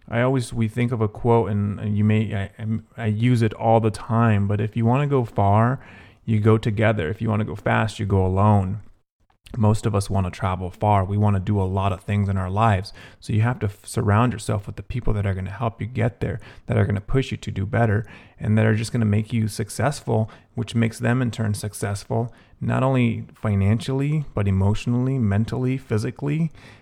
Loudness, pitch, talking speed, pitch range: -22 LUFS, 110 Hz, 230 wpm, 100-115 Hz